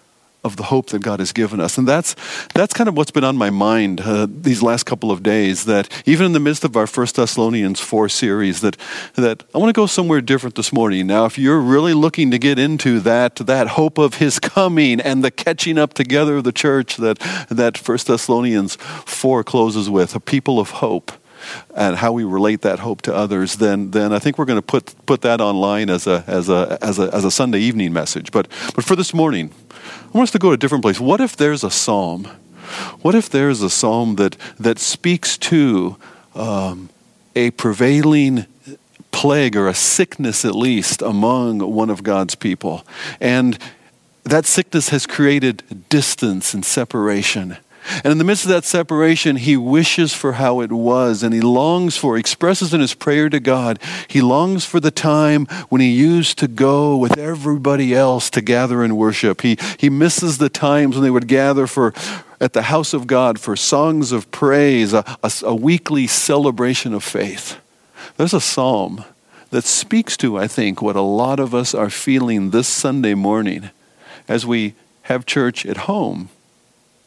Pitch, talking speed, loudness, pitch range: 130 Hz, 195 wpm, -16 LUFS, 110-150 Hz